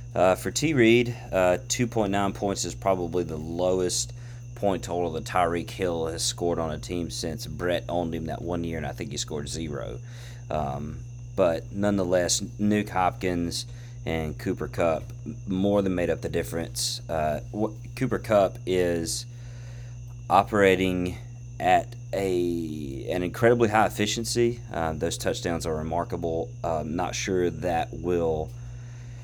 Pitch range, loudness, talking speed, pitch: 90-120 Hz, -26 LUFS, 145 wpm, 105 Hz